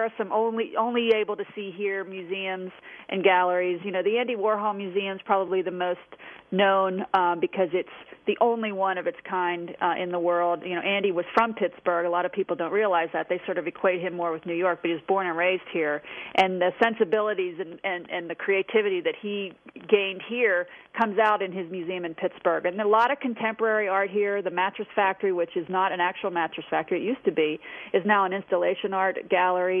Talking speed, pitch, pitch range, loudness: 220 wpm, 190 Hz, 180-205 Hz, -26 LUFS